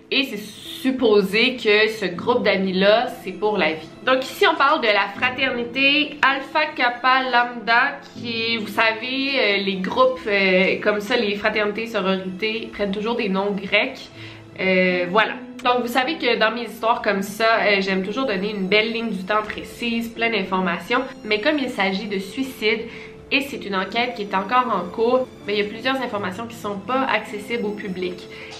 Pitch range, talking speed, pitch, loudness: 200-245 Hz, 180 wpm, 220 Hz, -20 LUFS